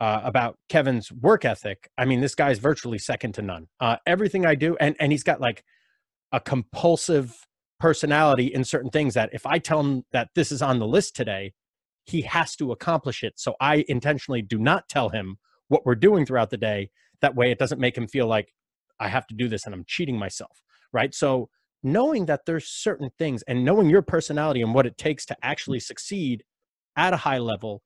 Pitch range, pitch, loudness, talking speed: 115-155 Hz, 130 Hz, -24 LUFS, 220 wpm